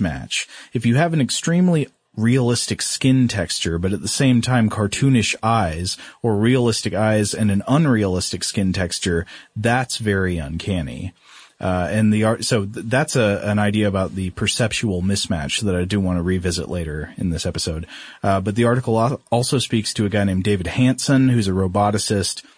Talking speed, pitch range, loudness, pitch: 175 wpm, 95-120 Hz, -20 LUFS, 105 Hz